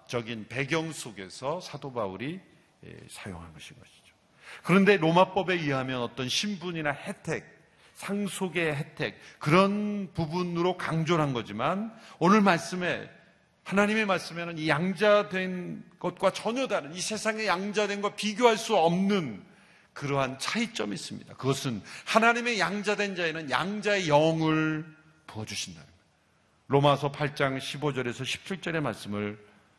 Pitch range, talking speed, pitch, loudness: 145-200 Hz, 290 characters per minute, 170 Hz, -28 LUFS